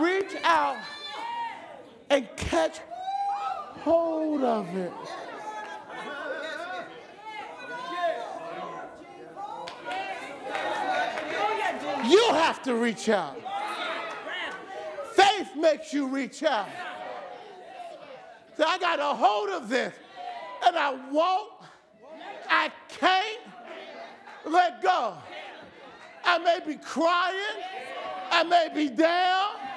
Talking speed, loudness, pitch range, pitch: 80 wpm, -27 LUFS, 300-390 Hz, 345 Hz